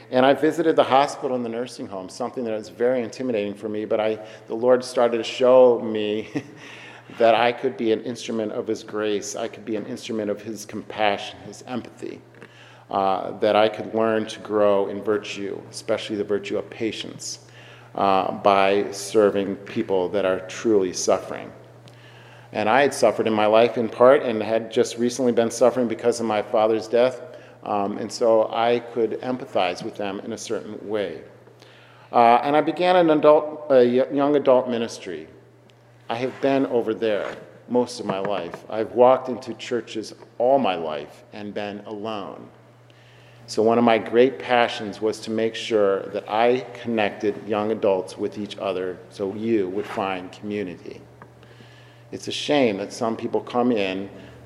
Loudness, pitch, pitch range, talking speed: -22 LUFS, 110 Hz, 105-125 Hz, 175 wpm